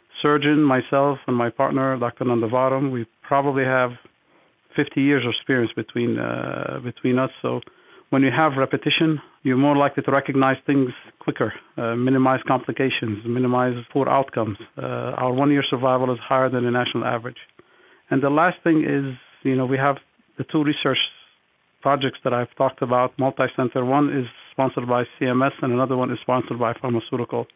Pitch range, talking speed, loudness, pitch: 125-140 Hz, 165 wpm, -22 LUFS, 130 Hz